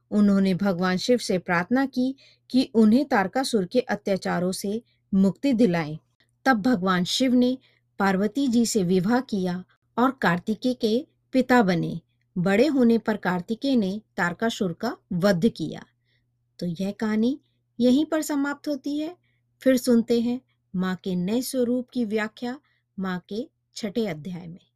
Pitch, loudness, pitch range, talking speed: 215 Hz, -24 LUFS, 185-250 Hz, 145 wpm